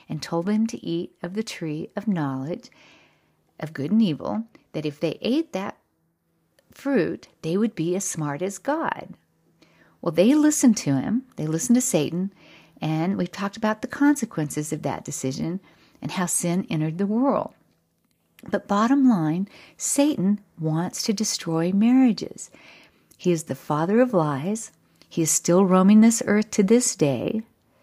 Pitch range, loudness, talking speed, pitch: 160-225 Hz, -23 LUFS, 160 wpm, 190 Hz